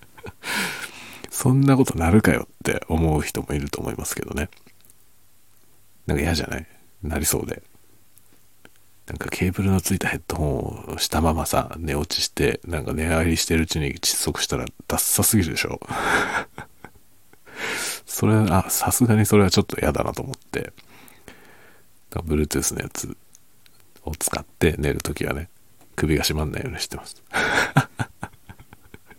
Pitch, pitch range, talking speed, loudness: 90 Hz, 75-105 Hz, 310 characters per minute, -23 LUFS